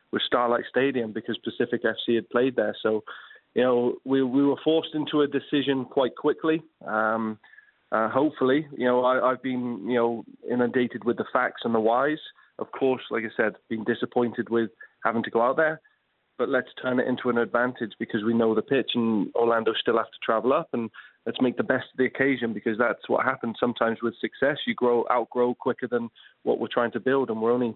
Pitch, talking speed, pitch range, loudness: 120 Hz, 210 wpm, 115-130 Hz, -26 LUFS